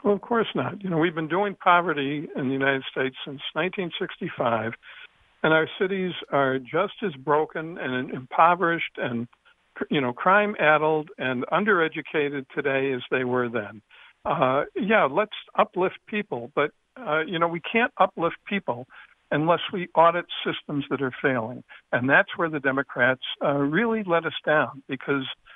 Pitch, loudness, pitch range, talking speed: 155 Hz, -24 LUFS, 135-185 Hz, 155 wpm